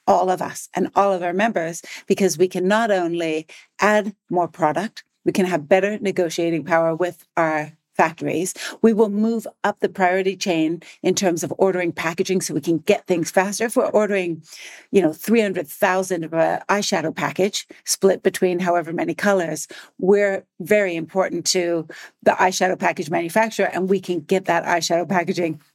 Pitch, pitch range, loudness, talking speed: 185 Hz, 170-195 Hz, -21 LUFS, 170 wpm